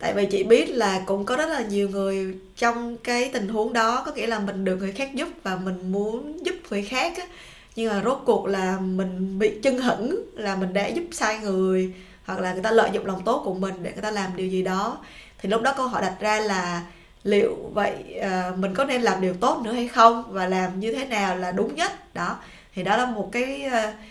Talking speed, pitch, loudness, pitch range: 240 wpm, 210 Hz, -24 LUFS, 190-240 Hz